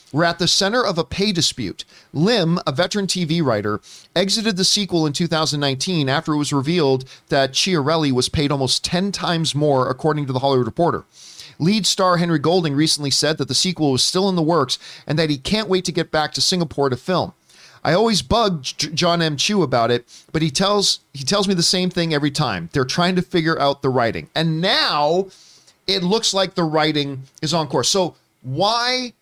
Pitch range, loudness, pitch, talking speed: 140-185 Hz, -19 LUFS, 160 Hz, 205 wpm